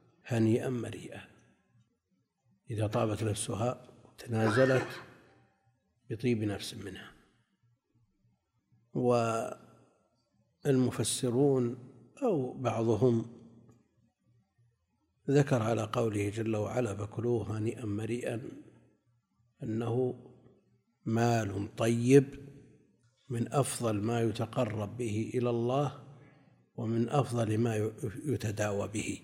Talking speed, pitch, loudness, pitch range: 70 wpm, 115 Hz, -32 LUFS, 110-125 Hz